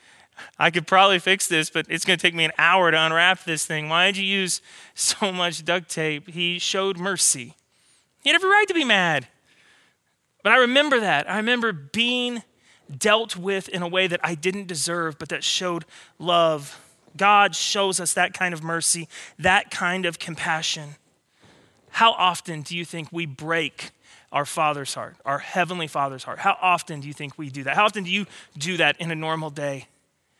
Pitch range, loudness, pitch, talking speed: 160-195 Hz, -21 LUFS, 175 Hz, 190 wpm